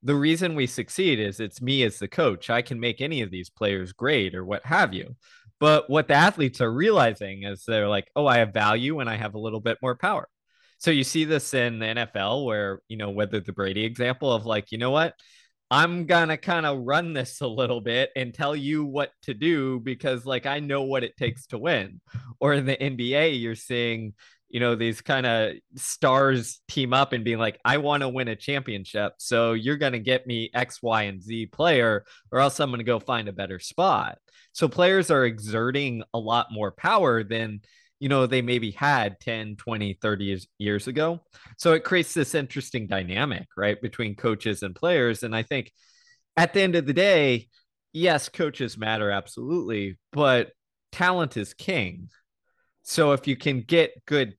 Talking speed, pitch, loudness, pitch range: 205 wpm, 125 Hz, -25 LUFS, 110-145 Hz